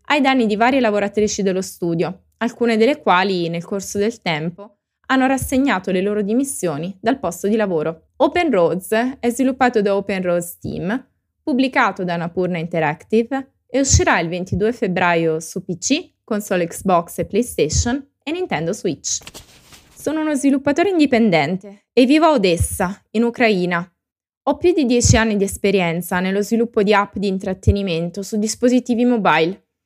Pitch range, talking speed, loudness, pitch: 180-250 Hz, 150 wpm, -18 LUFS, 210 Hz